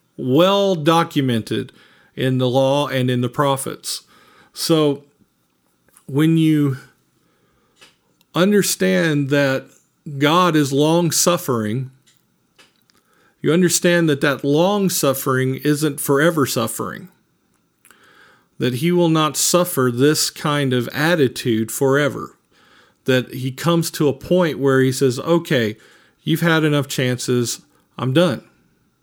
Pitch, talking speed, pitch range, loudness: 145 Hz, 110 wpm, 130-165 Hz, -18 LUFS